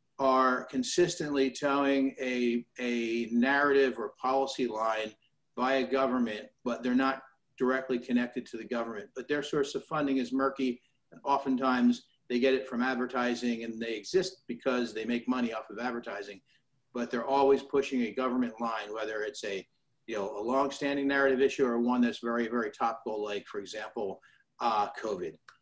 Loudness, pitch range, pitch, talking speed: -31 LUFS, 120-135 Hz, 125 Hz, 165 wpm